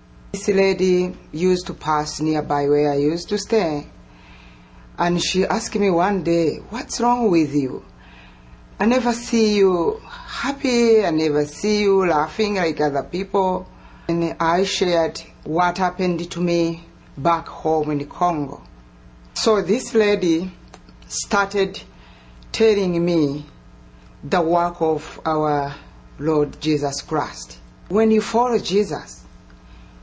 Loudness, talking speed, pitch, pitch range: -20 LUFS, 125 wpm, 170 Hz, 145-195 Hz